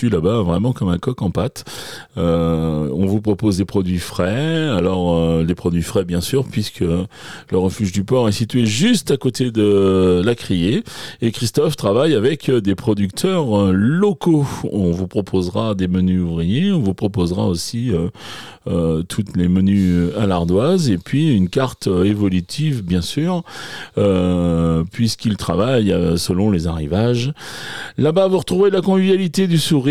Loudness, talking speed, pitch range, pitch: -18 LUFS, 155 wpm, 90-130 Hz, 100 Hz